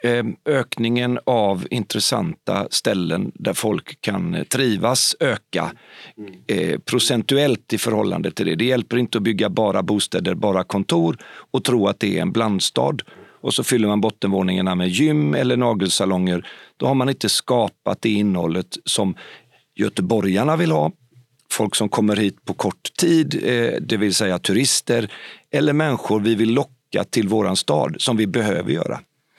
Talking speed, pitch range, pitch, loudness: 155 wpm, 100-125 Hz, 110 Hz, -20 LUFS